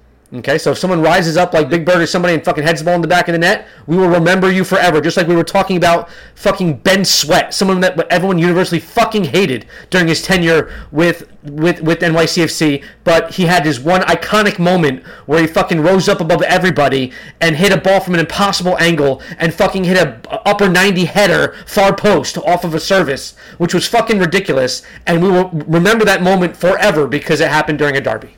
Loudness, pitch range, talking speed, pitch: -13 LUFS, 165-190 Hz, 215 wpm, 175 Hz